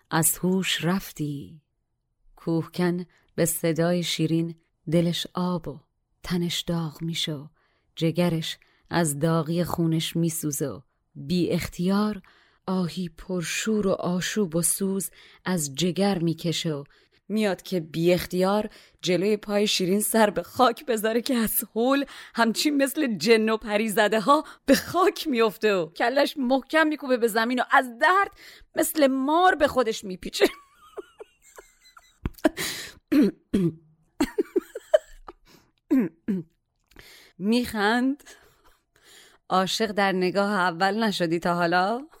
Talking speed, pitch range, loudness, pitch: 105 wpm, 170-245 Hz, -25 LUFS, 195 Hz